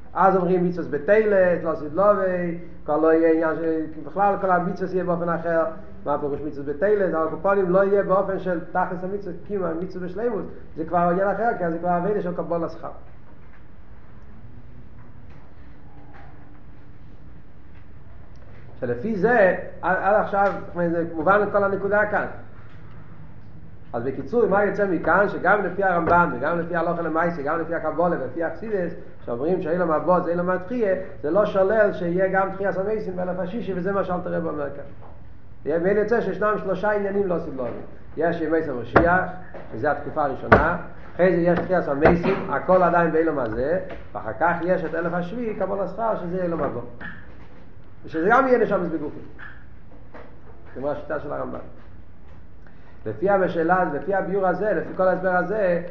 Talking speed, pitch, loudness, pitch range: 155 wpm, 175 Hz, -22 LUFS, 160-195 Hz